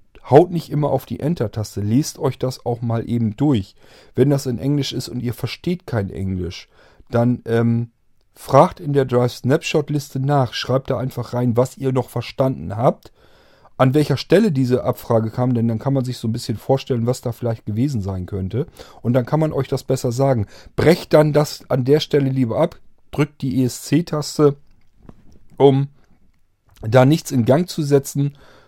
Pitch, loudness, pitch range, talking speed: 130 Hz, -19 LUFS, 115-140 Hz, 180 wpm